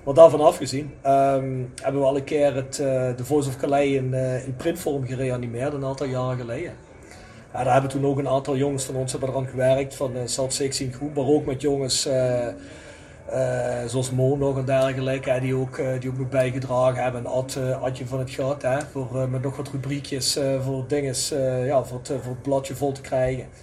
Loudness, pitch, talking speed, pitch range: -24 LUFS, 135 Hz, 215 wpm, 130-140 Hz